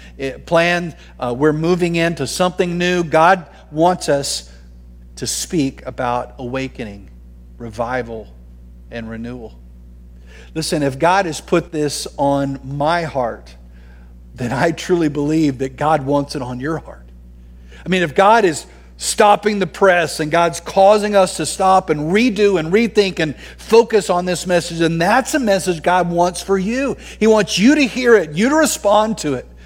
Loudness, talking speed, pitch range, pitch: -16 LUFS, 160 wpm, 120-185 Hz, 160 Hz